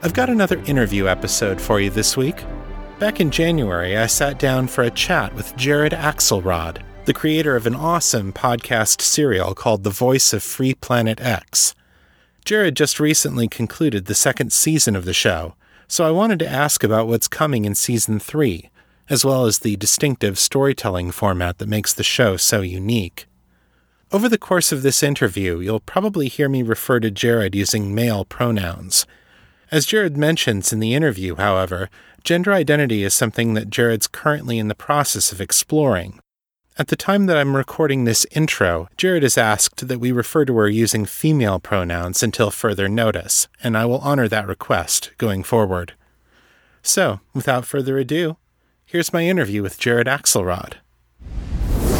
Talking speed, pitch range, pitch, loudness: 165 wpm, 100-145 Hz, 120 Hz, -18 LUFS